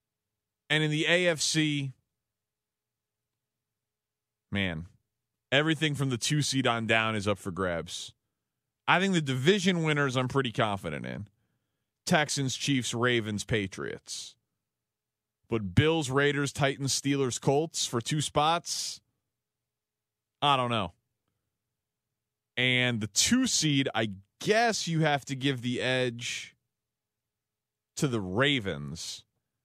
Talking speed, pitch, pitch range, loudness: 115 wpm, 120 Hz, 105-140 Hz, -28 LUFS